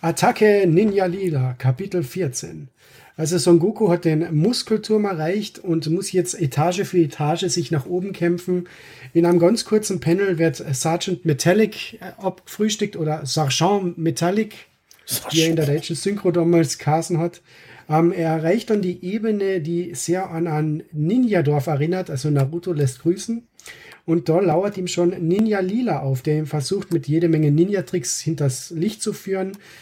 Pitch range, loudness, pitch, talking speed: 155-190 Hz, -21 LUFS, 170 Hz, 155 wpm